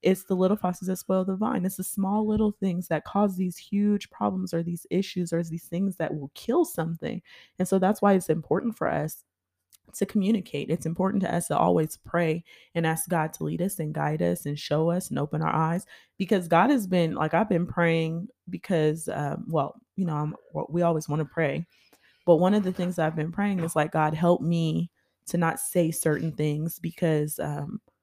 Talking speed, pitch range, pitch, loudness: 215 wpm, 160-190 Hz, 170 Hz, -27 LUFS